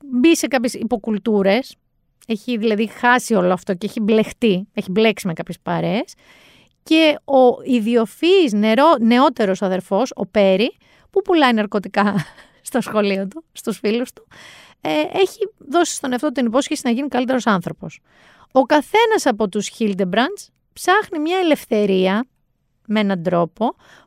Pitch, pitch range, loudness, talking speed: 230 Hz, 205-280 Hz, -18 LUFS, 135 wpm